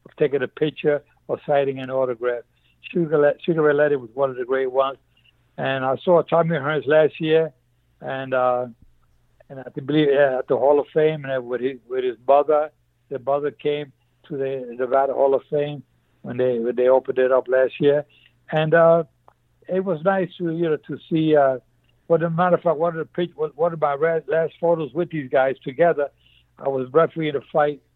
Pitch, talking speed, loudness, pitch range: 145 Hz, 200 wpm, -21 LUFS, 130-160 Hz